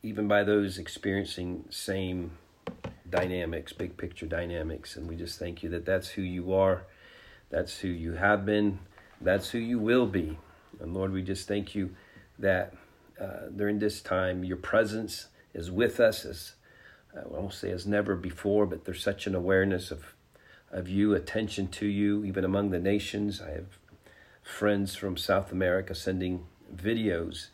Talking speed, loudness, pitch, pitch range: 165 wpm, -30 LUFS, 95 Hz, 90-105 Hz